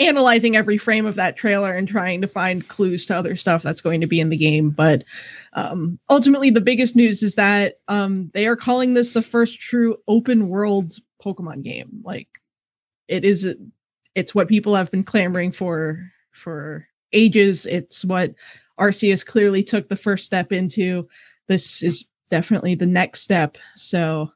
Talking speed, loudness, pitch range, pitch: 170 wpm, -18 LUFS, 175-215 Hz, 195 Hz